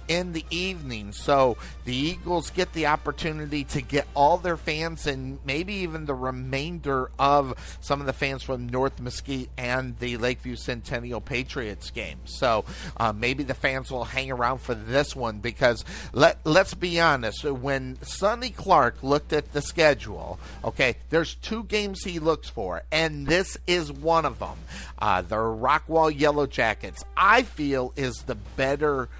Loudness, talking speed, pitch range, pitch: -26 LUFS, 160 wpm, 125-160 Hz, 140 Hz